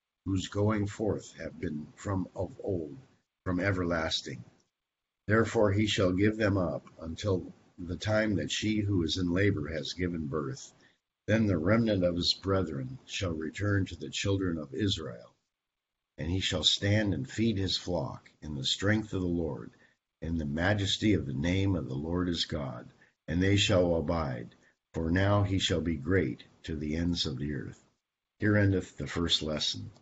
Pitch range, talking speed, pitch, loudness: 80-100 Hz, 175 wpm, 90 Hz, -30 LUFS